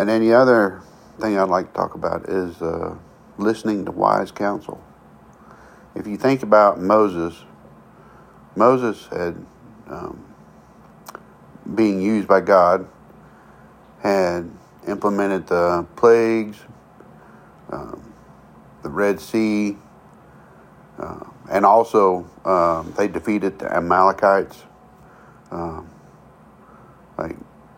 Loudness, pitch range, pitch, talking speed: -19 LUFS, 85-105 Hz, 100 Hz, 100 wpm